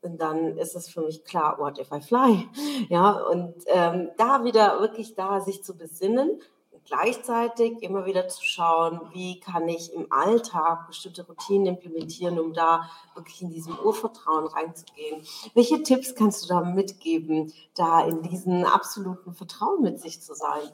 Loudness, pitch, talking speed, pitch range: -25 LUFS, 180 Hz, 165 wpm, 165-205 Hz